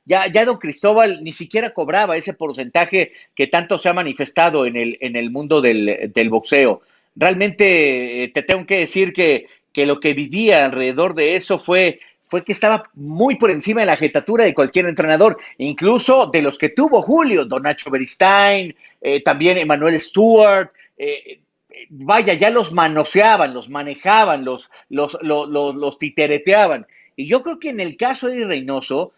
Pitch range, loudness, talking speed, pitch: 145-215 Hz, -16 LUFS, 175 wpm, 180 Hz